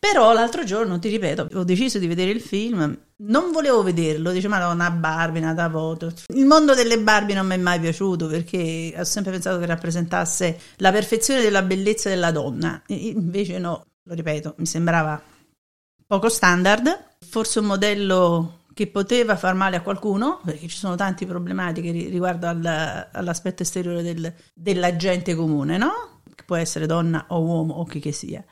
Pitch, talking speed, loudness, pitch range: 180 Hz, 175 wpm, -21 LUFS, 165-205 Hz